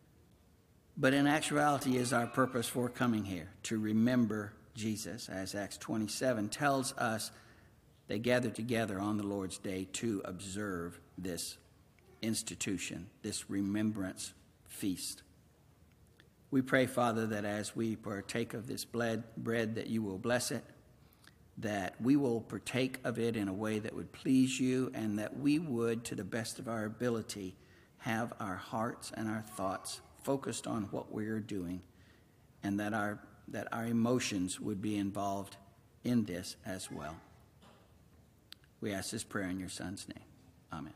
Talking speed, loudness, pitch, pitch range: 150 wpm, -36 LUFS, 110 Hz, 100-120 Hz